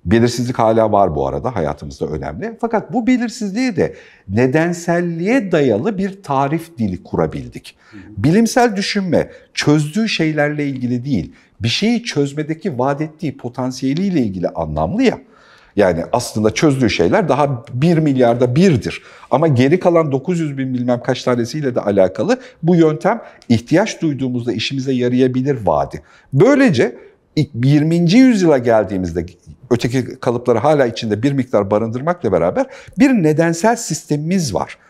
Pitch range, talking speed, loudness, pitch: 120-175 Hz, 125 wpm, -16 LUFS, 140 Hz